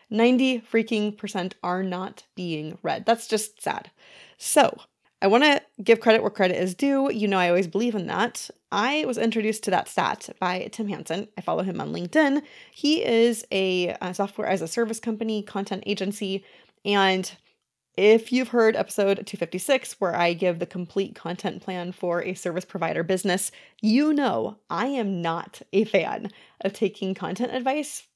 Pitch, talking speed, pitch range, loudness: 205 Hz, 175 wpm, 185-230 Hz, -25 LUFS